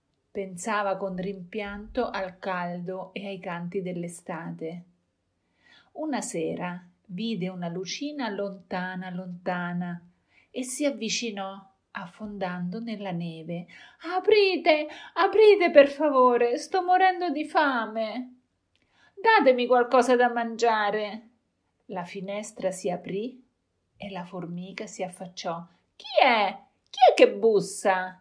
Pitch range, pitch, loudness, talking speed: 185-250 Hz, 200 Hz, -25 LUFS, 105 wpm